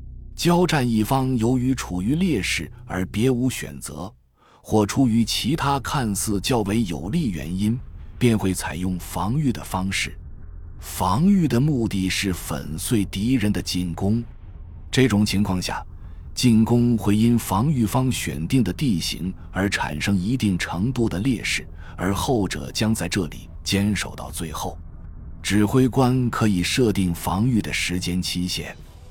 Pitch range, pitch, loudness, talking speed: 85-115 Hz, 95 Hz, -22 LUFS, 210 characters per minute